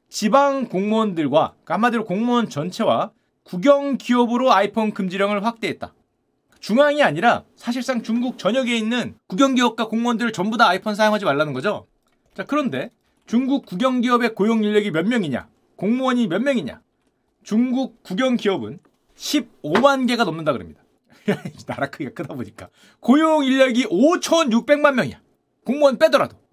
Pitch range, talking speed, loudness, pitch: 215-265 Hz, 330 characters per minute, -20 LUFS, 240 Hz